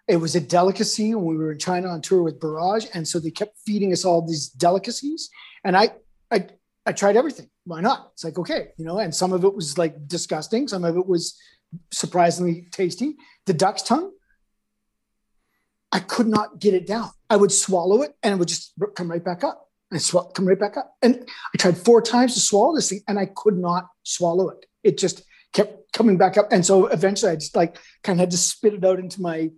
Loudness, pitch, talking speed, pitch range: -21 LUFS, 190 Hz, 225 wpm, 175-215 Hz